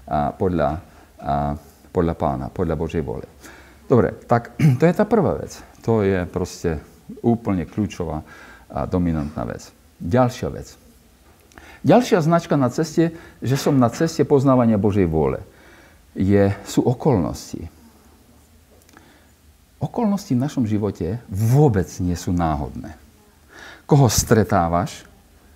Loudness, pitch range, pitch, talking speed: -20 LUFS, 80-125 Hz, 95 Hz, 115 wpm